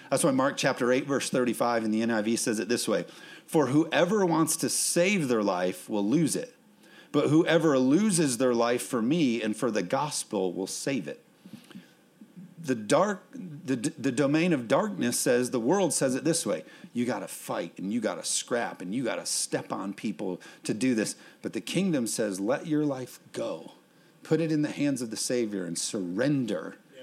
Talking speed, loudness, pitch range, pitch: 190 wpm, -28 LUFS, 115-160 Hz, 130 Hz